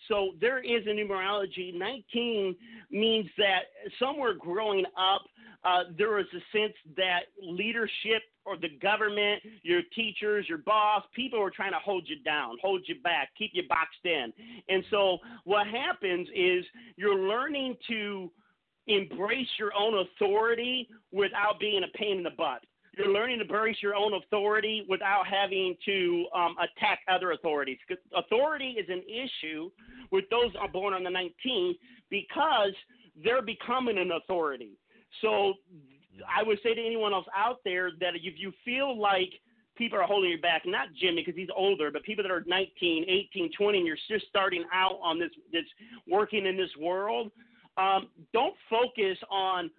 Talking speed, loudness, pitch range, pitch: 160 wpm, -29 LUFS, 185-230 Hz, 205 Hz